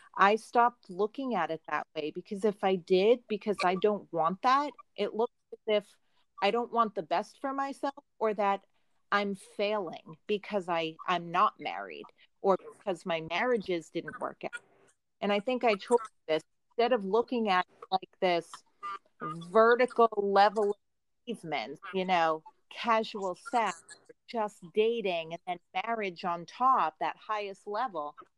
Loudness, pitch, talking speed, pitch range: -31 LUFS, 205 Hz, 155 wpm, 180-235 Hz